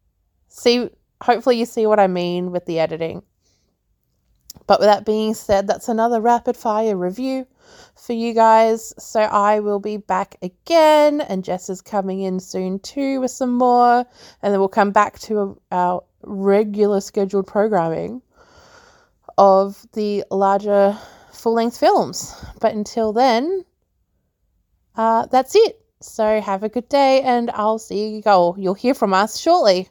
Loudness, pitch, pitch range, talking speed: -18 LUFS, 215 Hz, 195-240 Hz, 155 wpm